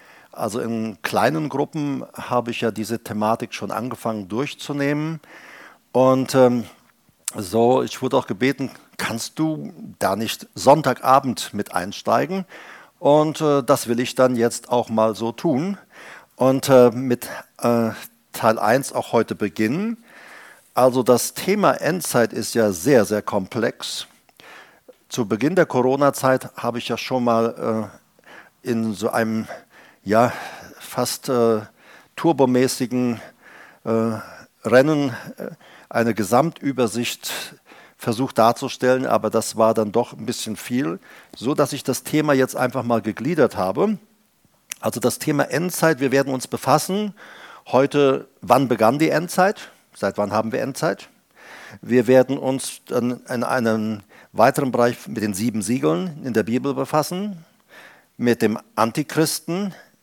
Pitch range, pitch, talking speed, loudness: 115-145 Hz, 125 Hz, 135 wpm, -21 LUFS